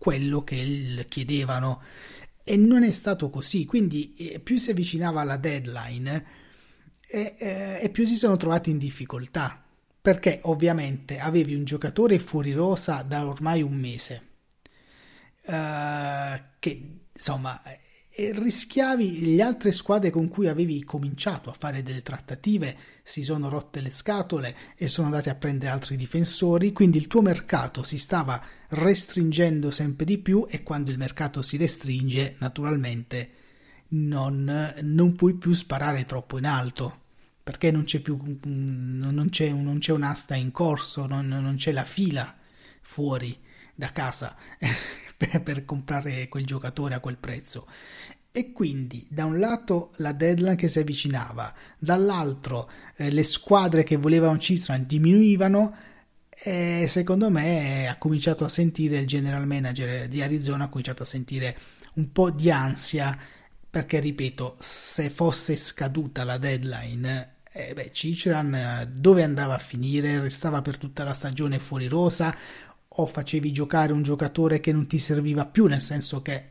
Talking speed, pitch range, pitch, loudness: 145 wpm, 135-170 Hz, 150 Hz, -26 LUFS